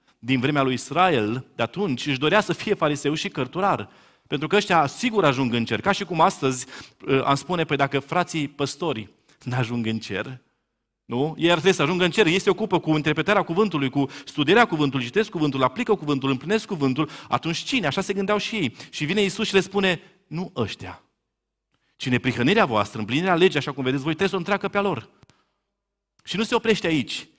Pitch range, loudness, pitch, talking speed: 135-195 Hz, -23 LUFS, 155 Hz, 205 wpm